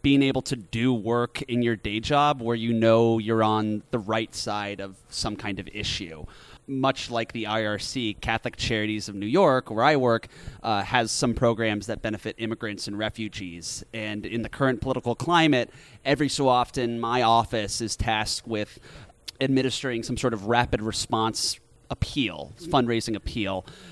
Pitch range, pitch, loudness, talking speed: 110-125 Hz, 115 Hz, -26 LUFS, 165 wpm